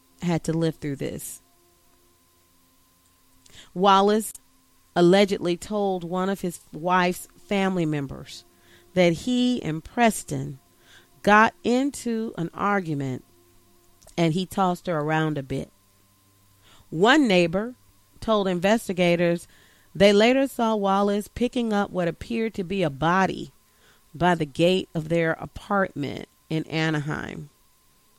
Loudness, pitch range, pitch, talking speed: -23 LUFS, 135-200 Hz, 170 Hz, 115 wpm